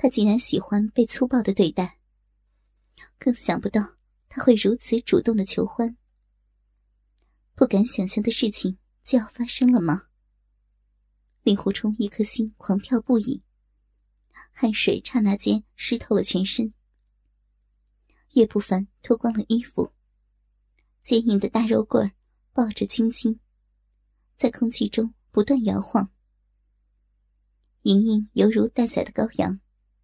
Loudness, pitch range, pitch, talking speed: -23 LUFS, 185-235 Hz, 215 Hz, 185 characters per minute